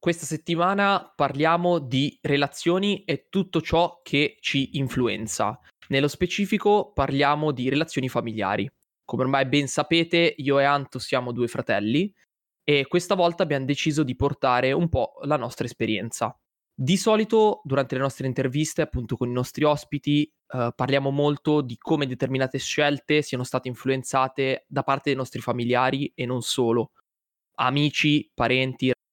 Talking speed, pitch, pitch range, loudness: 145 wpm, 140 Hz, 130-155 Hz, -24 LUFS